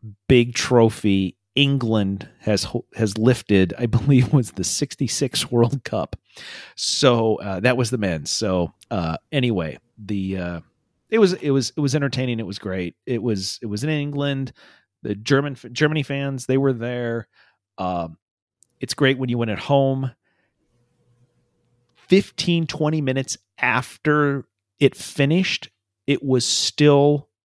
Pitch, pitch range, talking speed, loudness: 120 Hz, 105-140 Hz, 140 wpm, -21 LUFS